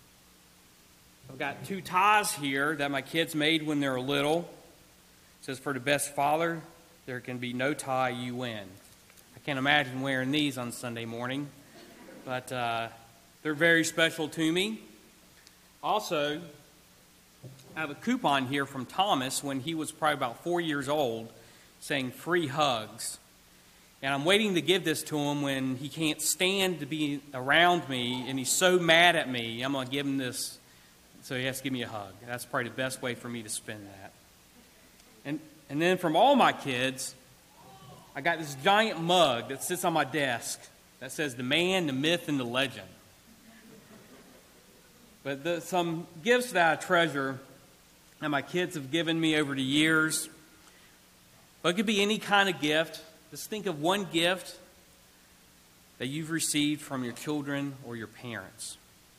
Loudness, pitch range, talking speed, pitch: -29 LUFS, 125-165 Hz, 170 wpm, 145 Hz